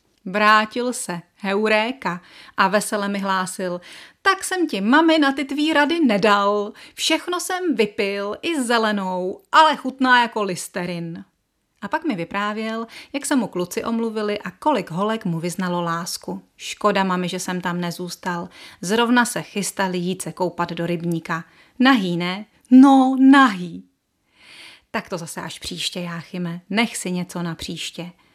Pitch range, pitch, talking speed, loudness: 180-245 Hz, 200 Hz, 145 wpm, -20 LUFS